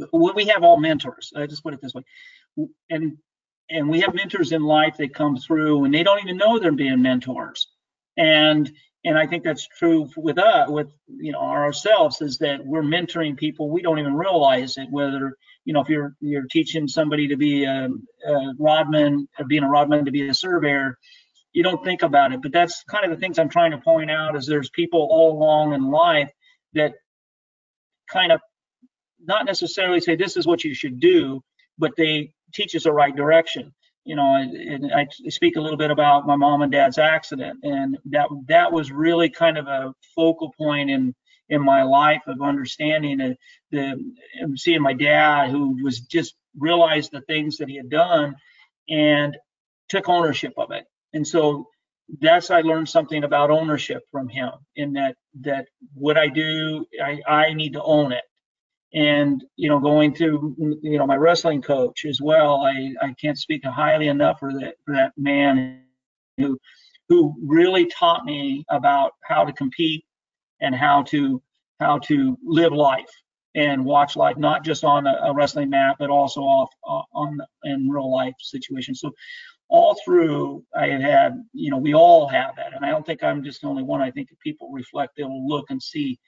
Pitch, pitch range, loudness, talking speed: 155 Hz, 140-185 Hz, -20 LUFS, 190 wpm